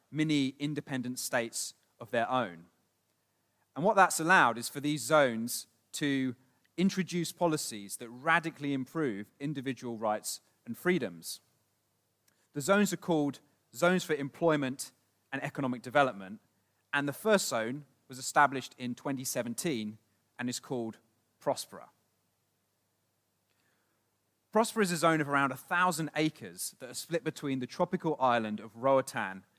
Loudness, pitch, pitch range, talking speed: -31 LUFS, 130 Hz, 115-155 Hz, 130 wpm